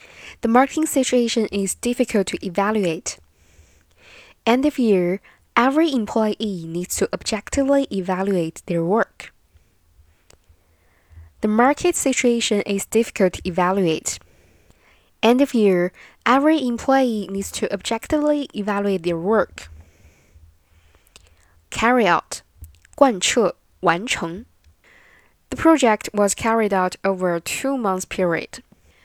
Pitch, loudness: 195 Hz, -20 LUFS